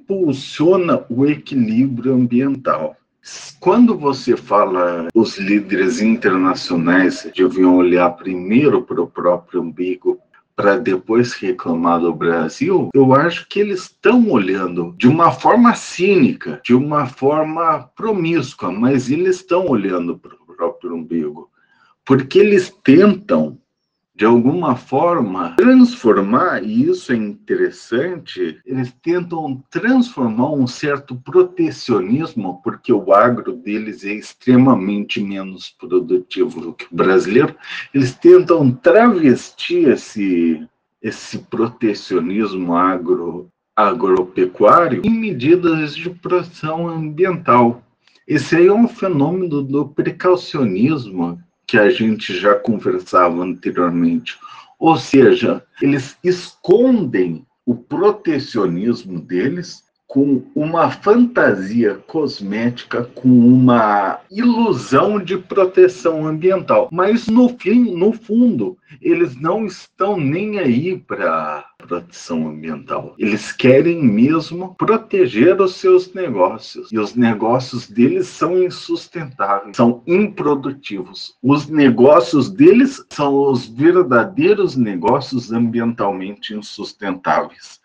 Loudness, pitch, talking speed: -15 LUFS, 160 Hz, 105 wpm